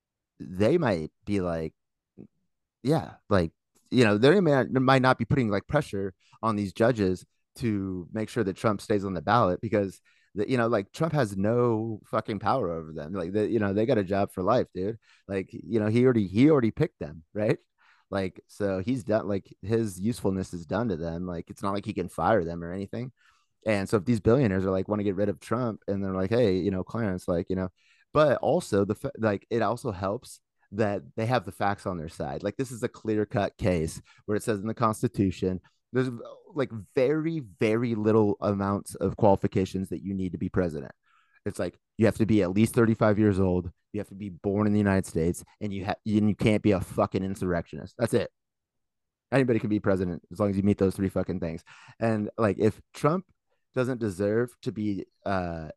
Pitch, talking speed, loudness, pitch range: 105 Hz, 215 wpm, -27 LUFS, 95-115 Hz